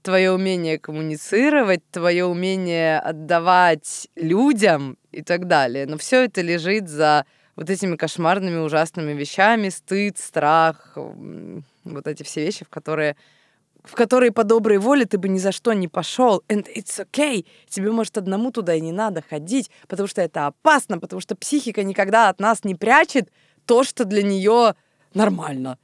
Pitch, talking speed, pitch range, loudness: 190 Hz, 160 wpm, 160-220 Hz, -20 LUFS